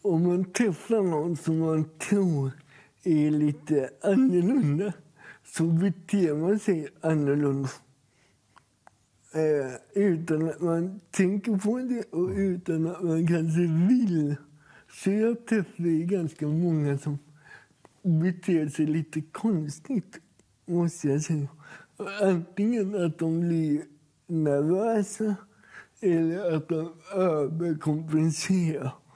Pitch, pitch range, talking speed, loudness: 165 Hz, 150-190 Hz, 105 wpm, -27 LUFS